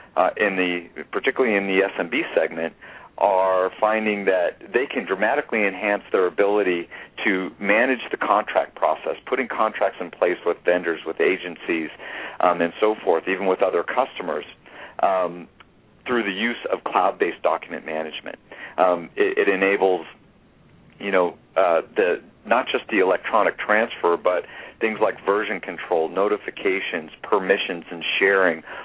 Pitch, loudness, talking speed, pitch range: 95 Hz, -22 LUFS, 140 wpm, 85-100 Hz